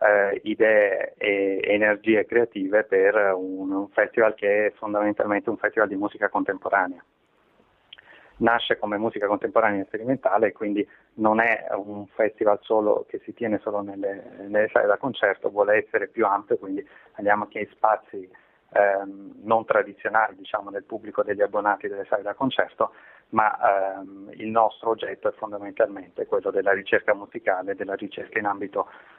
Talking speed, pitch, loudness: 150 wpm, 110 Hz, -24 LUFS